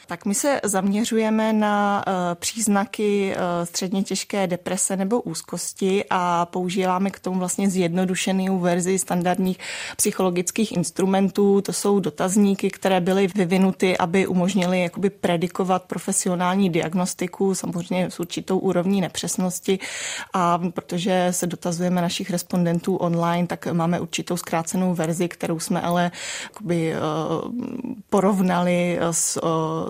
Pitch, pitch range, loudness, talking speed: 185 Hz, 175-195 Hz, -22 LUFS, 110 wpm